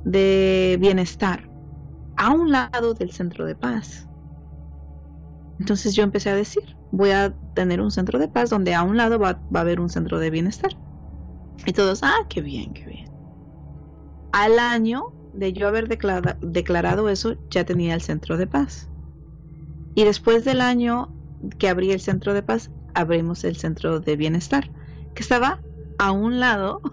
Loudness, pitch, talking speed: -21 LUFS, 185 Hz, 165 wpm